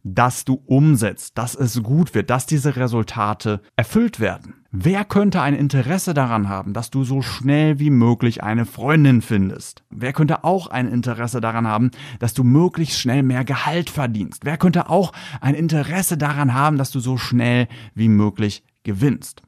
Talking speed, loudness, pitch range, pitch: 170 wpm, -19 LUFS, 115-150 Hz, 130 Hz